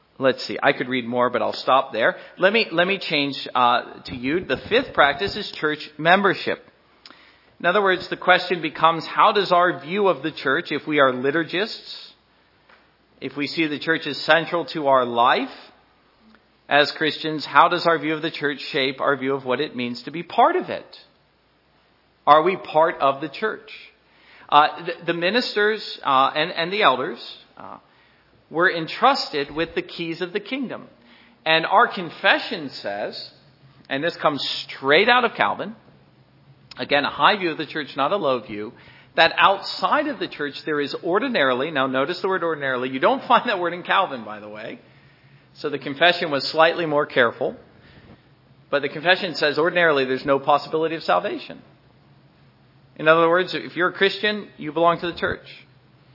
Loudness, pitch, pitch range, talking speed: -21 LUFS, 160 Hz, 140-180 Hz, 180 wpm